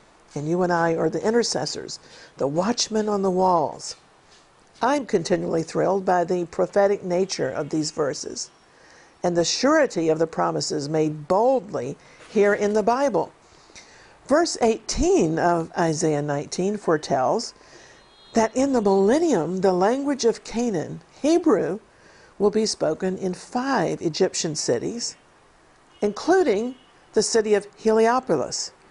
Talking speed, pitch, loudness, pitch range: 125 wpm, 195 Hz, -23 LUFS, 170-230 Hz